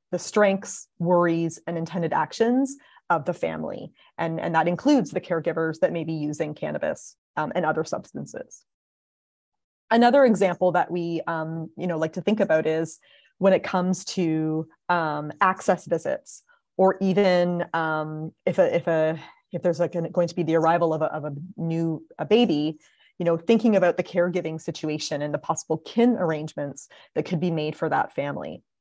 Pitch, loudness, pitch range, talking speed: 170 Hz, -24 LUFS, 160-190 Hz, 175 wpm